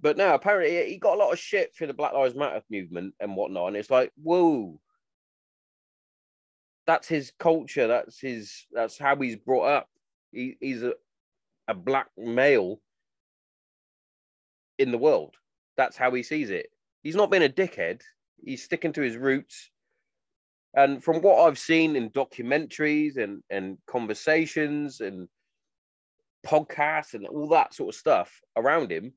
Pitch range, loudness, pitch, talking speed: 125-175 Hz, -25 LUFS, 150 Hz, 155 wpm